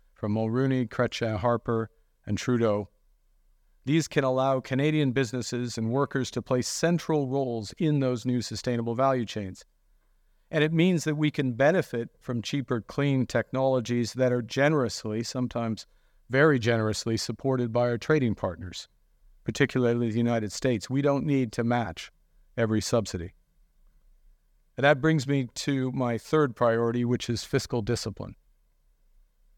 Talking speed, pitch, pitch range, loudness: 140 wpm, 125 Hz, 115-135 Hz, -27 LUFS